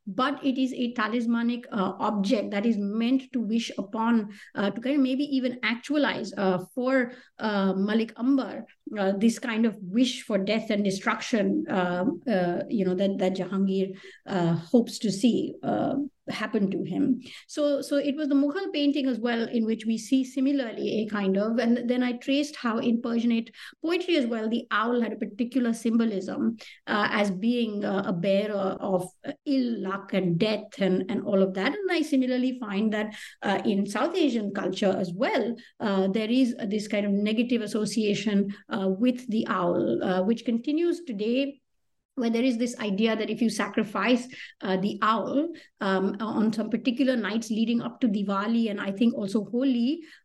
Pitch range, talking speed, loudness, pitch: 200-255 Hz, 185 wpm, -27 LUFS, 225 Hz